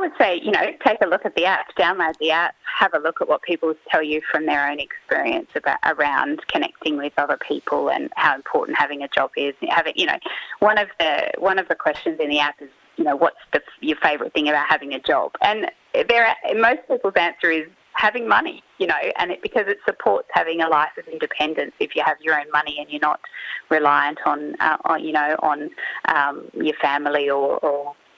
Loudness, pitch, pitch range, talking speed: -20 LUFS, 160 Hz, 145-230 Hz, 225 wpm